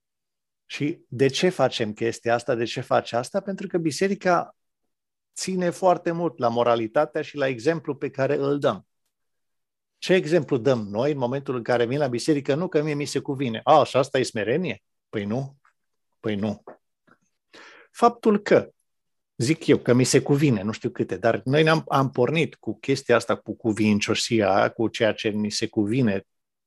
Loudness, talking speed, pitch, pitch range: -23 LUFS, 175 wpm, 135 Hz, 115-155 Hz